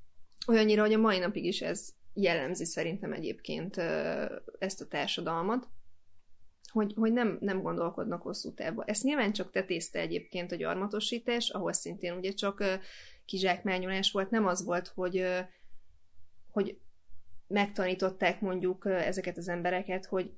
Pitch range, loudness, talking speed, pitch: 170-205 Hz, -32 LUFS, 130 wpm, 185 Hz